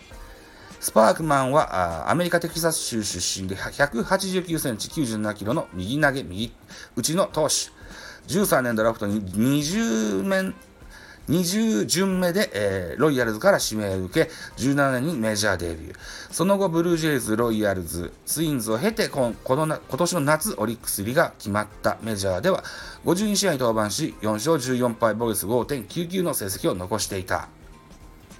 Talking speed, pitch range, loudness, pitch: 280 characters per minute, 100-160 Hz, -24 LUFS, 115 Hz